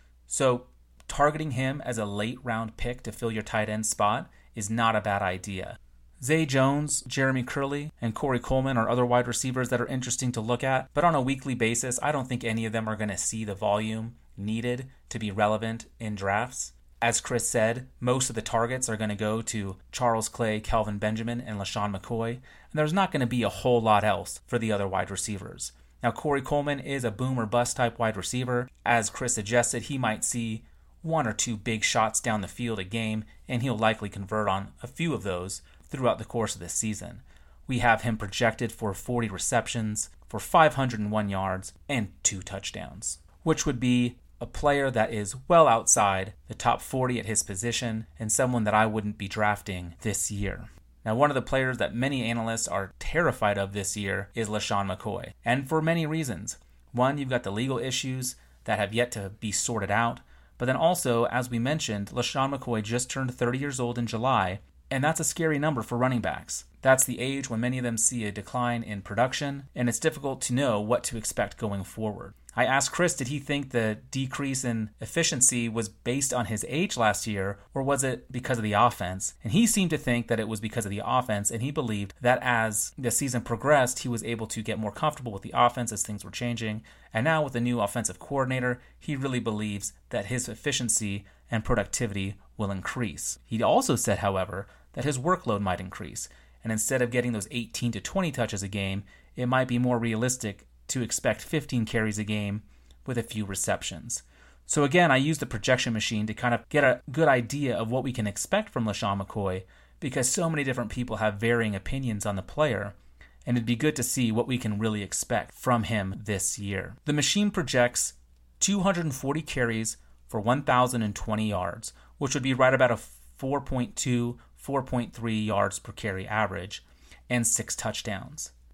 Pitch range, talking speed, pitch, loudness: 105-130 Hz, 200 wpm, 115 Hz, -28 LUFS